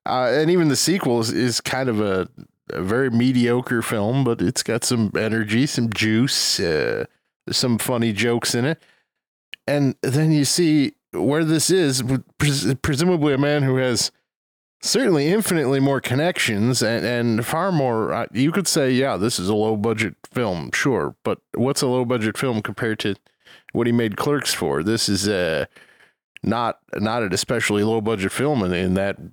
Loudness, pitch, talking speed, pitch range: -20 LUFS, 125 Hz, 170 wpm, 110-145 Hz